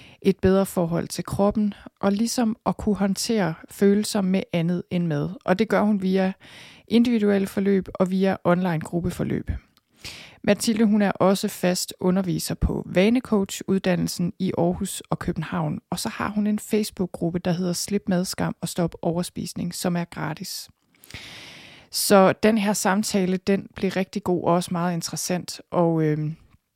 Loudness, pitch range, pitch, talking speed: -23 LUFS, 175-205 Hz, 190 Hz, 155 wpm